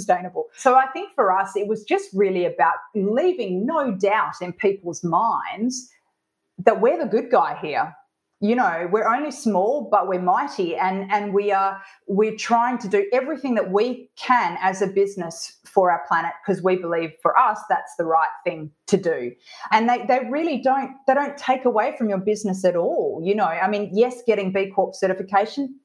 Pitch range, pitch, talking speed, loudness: 185-245 Hz, 205 Hz, 190 wpm, -22 LUFS